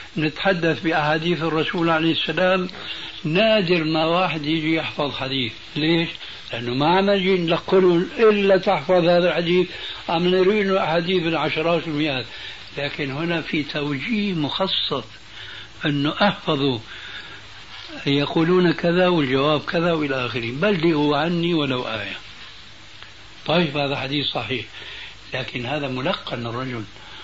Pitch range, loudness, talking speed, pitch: 140-175 Hz, -21 LUFS, 110 wpm, 160 Hz